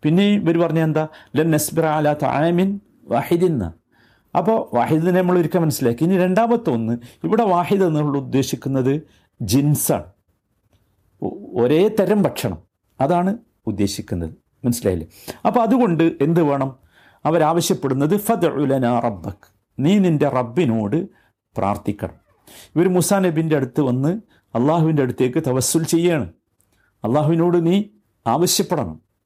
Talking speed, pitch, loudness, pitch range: 105 wpm, 150 Hz, -19 LUFS, 120-175 Hz